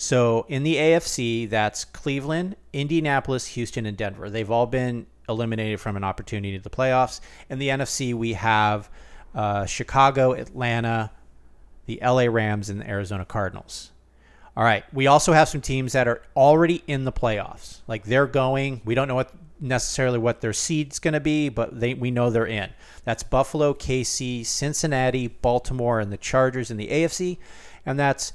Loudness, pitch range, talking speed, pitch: -23 LUFS, 110-135 Hz, 170 wpm, 125 Hz